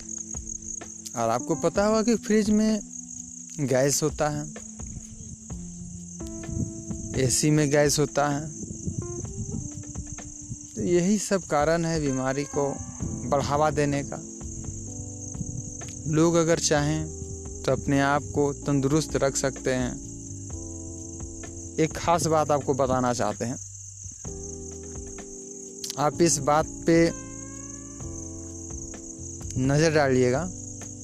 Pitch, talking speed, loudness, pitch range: 125 Hz, 95 wpm, -26 LUFS, 95-145 Hz